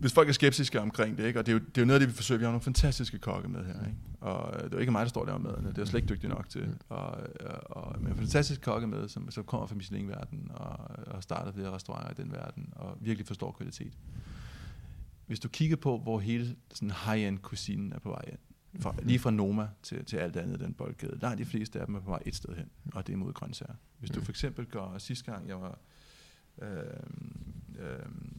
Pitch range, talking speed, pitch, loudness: 105-130 Hz, 250 wpm, 115 Hz, -34 LUFS